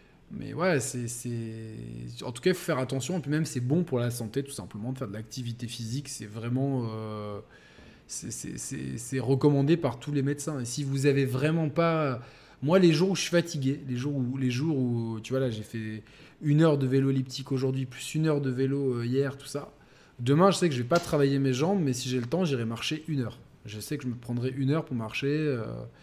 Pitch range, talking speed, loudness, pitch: 120-145 Hz, 245 wpm, -29 LUFS, 135 Hz